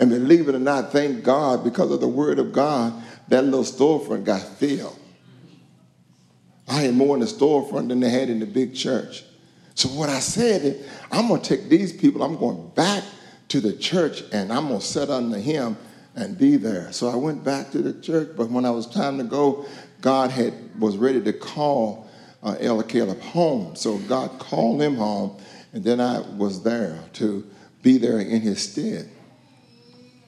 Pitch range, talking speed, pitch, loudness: 115-140 Hz, 195 wpm, 130 Hz, -22 LUFS